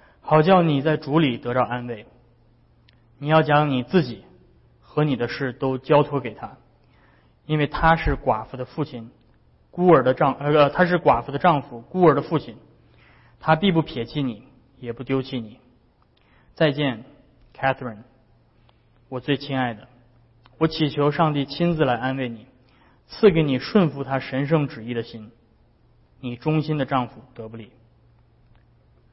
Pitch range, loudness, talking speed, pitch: 120-145 Hz, -22 LUFS, 230 characters per minute, 130 Hz